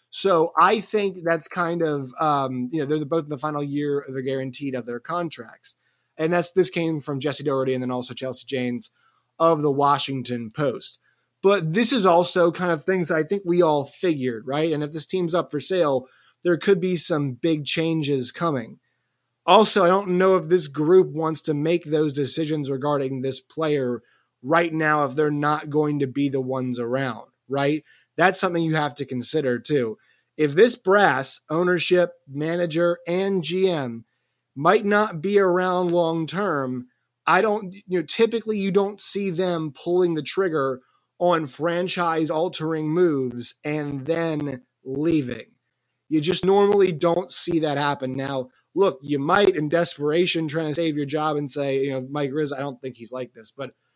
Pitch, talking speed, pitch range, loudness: 155 Hz, 180 wpm, 140-175 Hz, -23 LUFS